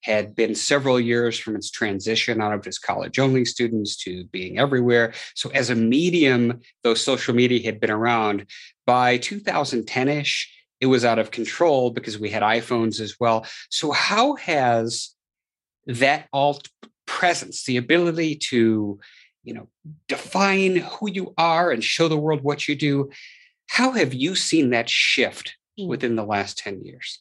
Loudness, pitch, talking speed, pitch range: -21 LUFS, 125 Hz, 160 wpm, 115-150 Hz